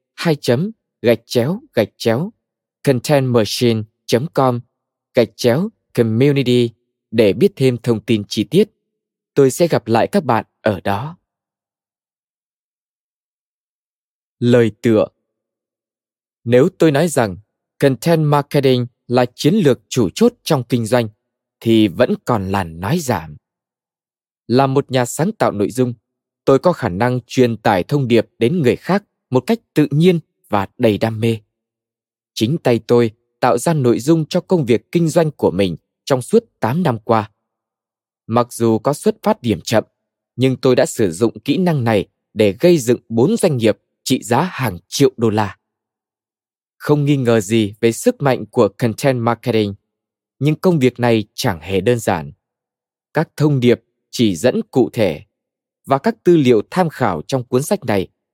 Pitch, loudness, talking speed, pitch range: 120 Hz, -17 LUFS, 160 wpm, 110-145 Hz